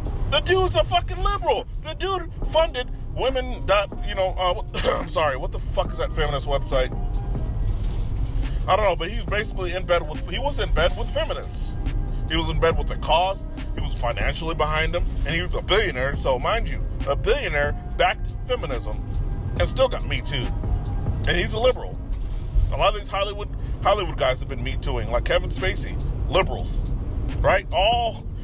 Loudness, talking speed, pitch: -24 LUFS, 185 wpm, 155 Hz